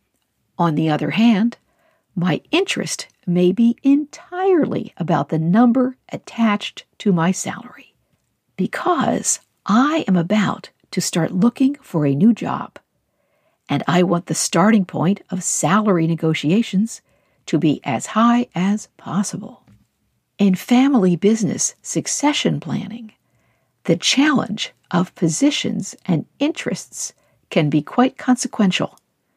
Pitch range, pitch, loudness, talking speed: 175-245 Hz, 205 Hz, -19 LUFS, 115 wpm